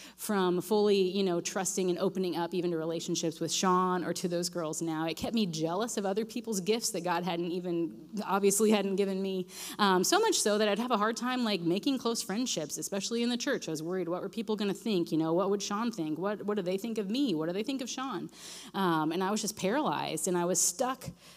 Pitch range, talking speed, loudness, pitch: 175-215 Hz, 255 wpm, -31 LUFS, 195 Hz